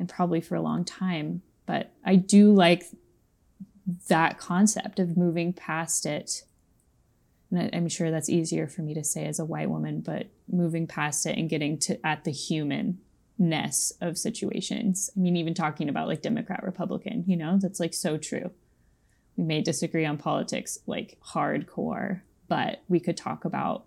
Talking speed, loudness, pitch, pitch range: 170 wpm, -27 LUFS, 175 Hz, 160-190 Hz